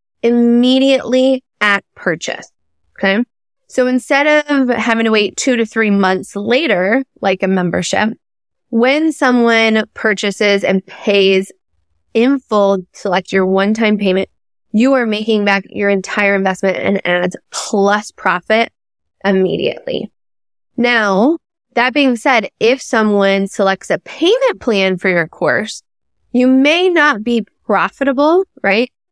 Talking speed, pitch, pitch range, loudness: 125 wpm, 220 Hz, 195-255 Hz, -14 LUFS